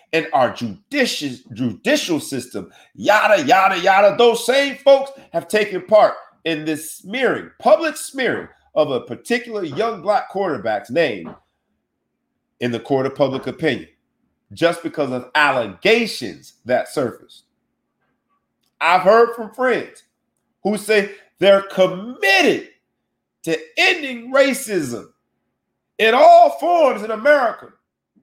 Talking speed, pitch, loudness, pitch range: 115 wpm, 215 Hz, -17 LUFS, 170-270 Hz